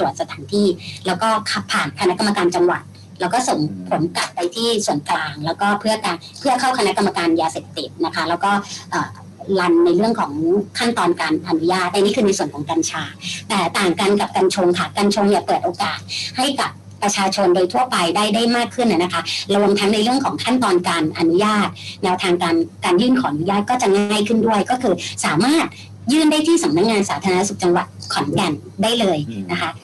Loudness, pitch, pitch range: -18 LUFS, 200 Hz, 175-225 Hz